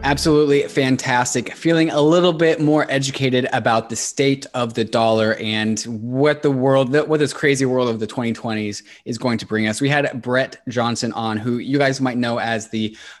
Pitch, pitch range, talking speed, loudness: 125 Hz, 115-140 Hz, 190 wpm, -19 LUFS